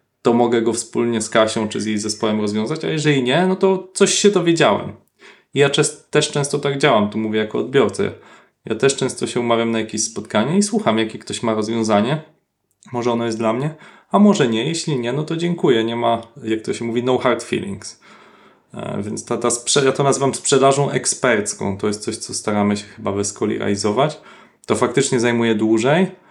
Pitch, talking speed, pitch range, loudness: 120 Hz, 205 wpm, 110-150 Hz, -18 LUFS